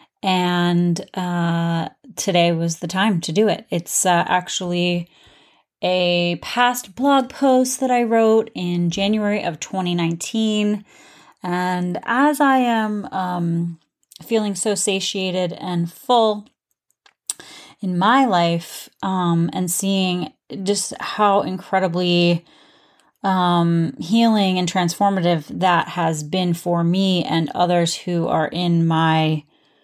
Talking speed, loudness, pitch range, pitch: 115 wpm, -19 LUFS, 170-205 Hz, 180 Hz